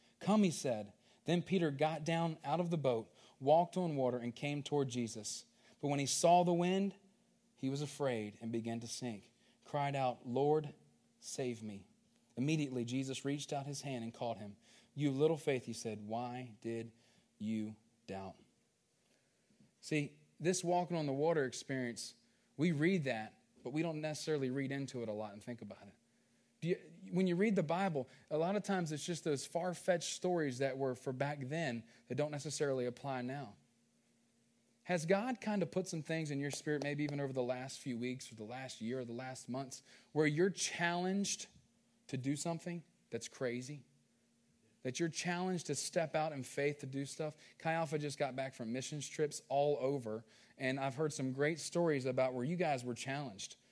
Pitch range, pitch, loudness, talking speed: 125-160 Hz, 140 Hz, -38 LUFS, 190 wpm